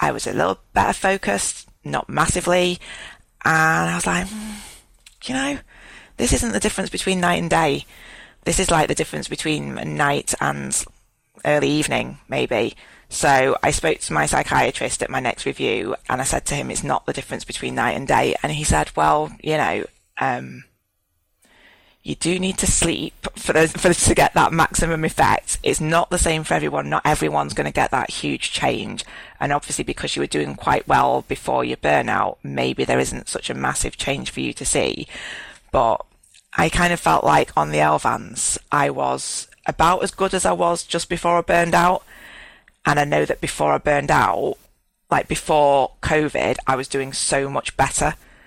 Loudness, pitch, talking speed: -20 LUFS, 155 Hz, 190 wpm